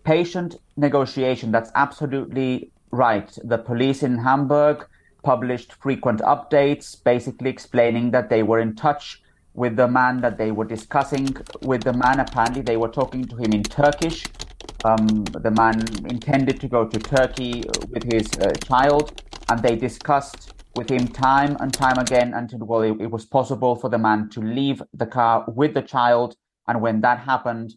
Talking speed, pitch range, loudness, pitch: 170 wpm, 115-135 Hz, -21 LUFS, 125 Hz